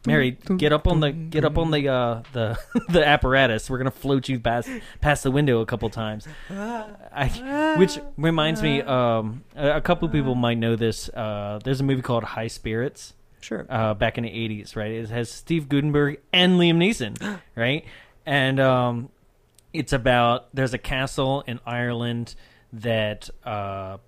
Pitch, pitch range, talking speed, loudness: 130 Hz, 115-150 Hz, 170 wpm, -23 LUFS